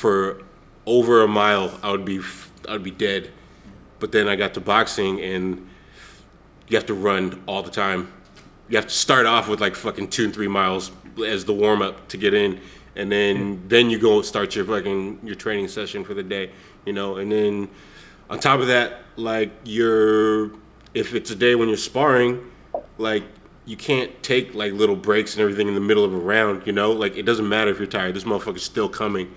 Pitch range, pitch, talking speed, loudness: 100-110 Hz, 105 Hz, 215 wpm, -21 LUFS